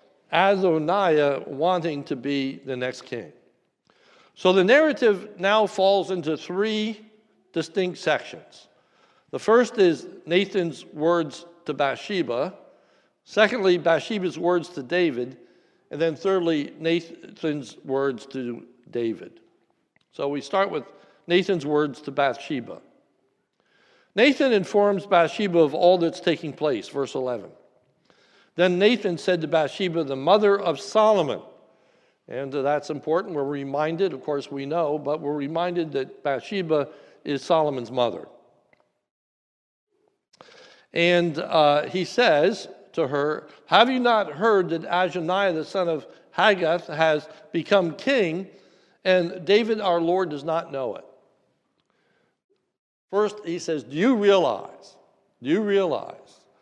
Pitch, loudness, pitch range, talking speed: 170 Hz, -23 LUFS, 150-195 Hz, 120 wpm